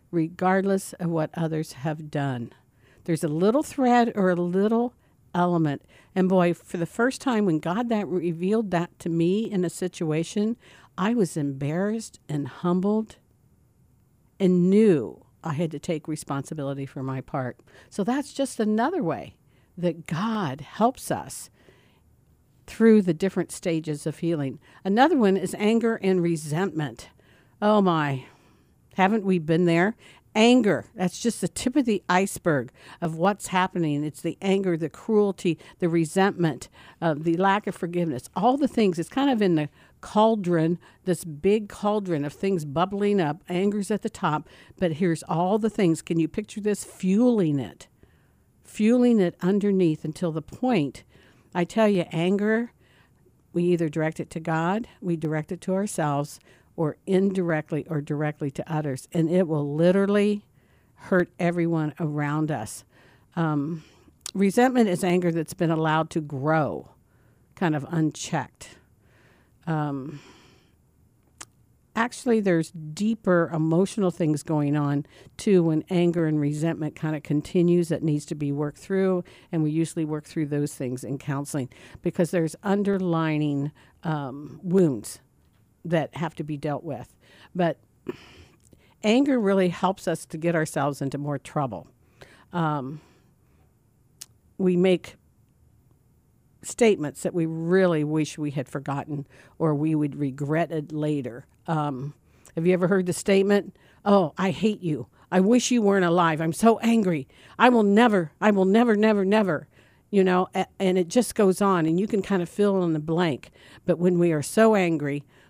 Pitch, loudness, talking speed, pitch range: 170 Hz, -25 LUFS, 150 wpm, 150-195 Hz